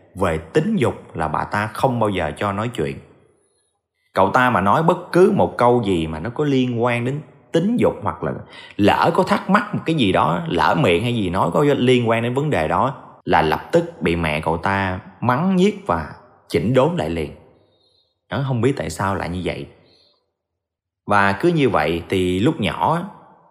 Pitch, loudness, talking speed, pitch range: 110 Hz, -19 LUFS, 205 wpm, 90-135 Hz